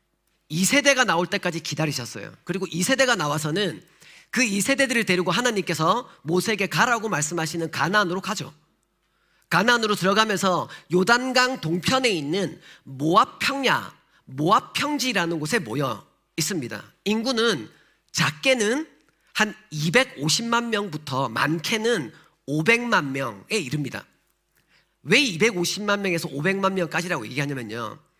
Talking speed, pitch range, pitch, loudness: 280 characters per minute, 160-230 Hz, 185 Hz, -23 LUFS